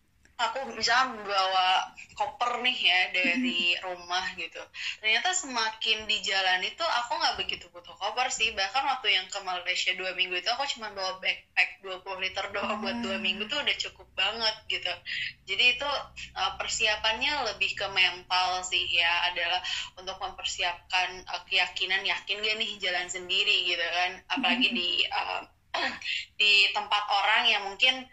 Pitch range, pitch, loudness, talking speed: 185-225 Hz, 195 Hz, -27 LUFS, 150 wpm